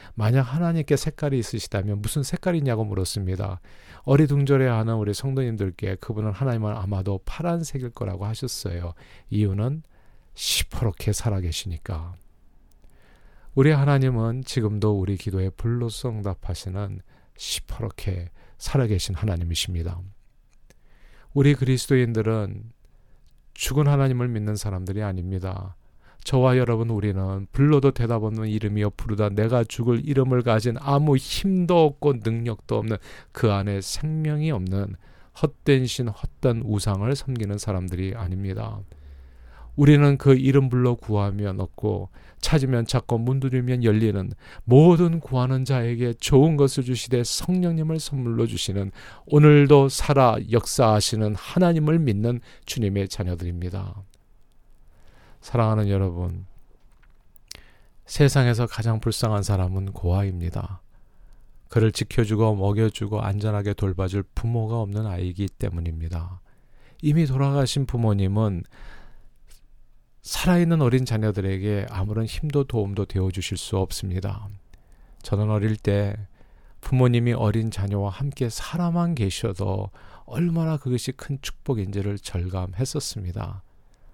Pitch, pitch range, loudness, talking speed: 110 Hz, 100-130 Hz, -23 LUFS, 295 characters per minute